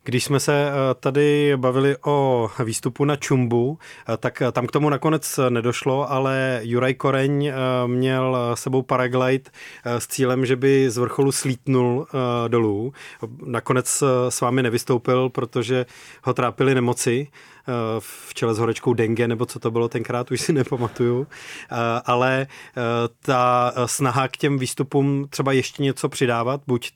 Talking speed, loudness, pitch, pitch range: 135 wpm, -21 LUFS, 130 Hz, 120-135 Hz